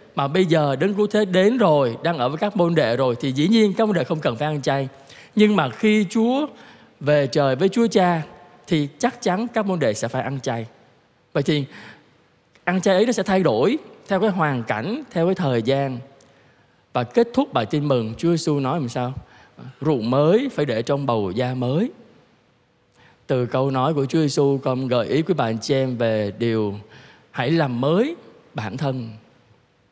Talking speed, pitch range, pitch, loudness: 205 wpm, 125-185 Hz, 145 Hz, -21 LUFS